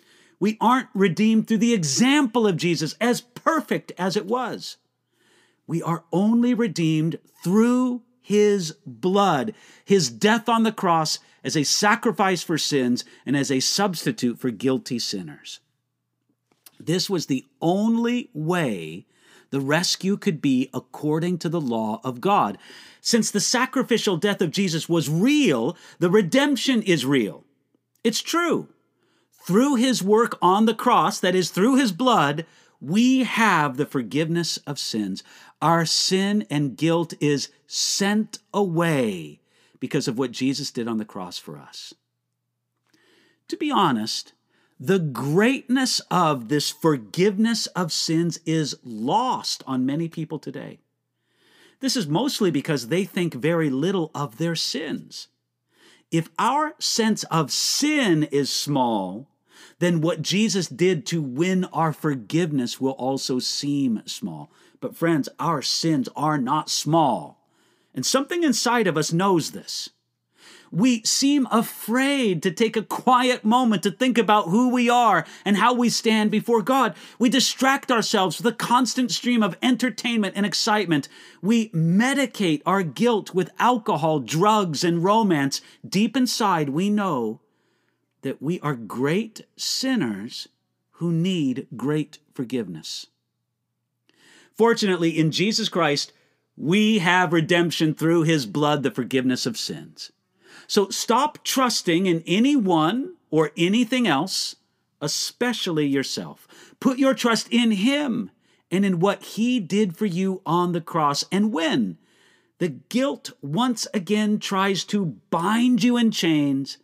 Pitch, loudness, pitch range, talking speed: 190 Hz, -22 LUFS, 155-230 Hz, 135 wpm